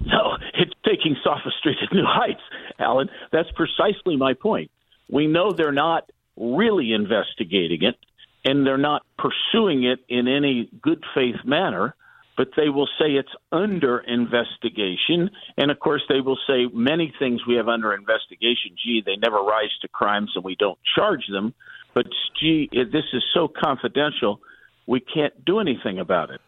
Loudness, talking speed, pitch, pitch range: -22 LUFS, 165 wpm, 135 Hz, 120-150 Hz